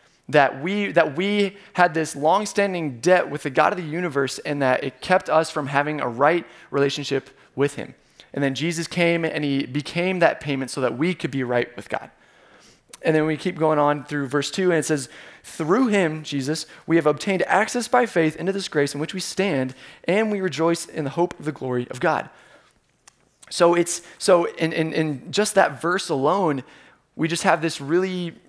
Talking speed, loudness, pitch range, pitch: 205 wpm, -22 LUFS, 145-180 Hz, 160 Hz